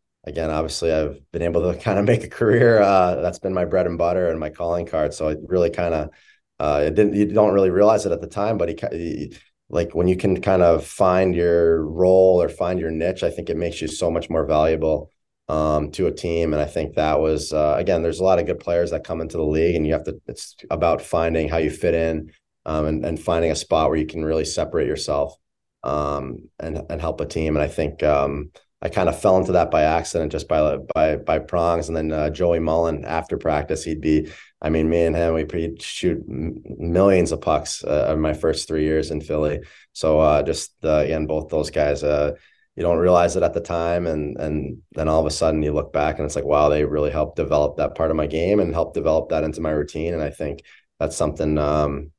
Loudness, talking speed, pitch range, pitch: -21 LUFS, 245 wpm, 75-85 Hz, 80 Hz